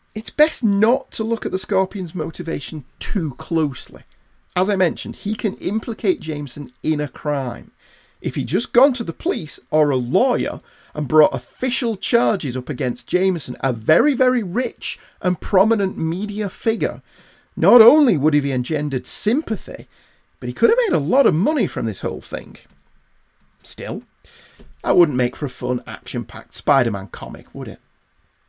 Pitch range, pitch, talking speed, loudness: 135-210 Hz, 165 Hz, 170 wpm, -20 LUFS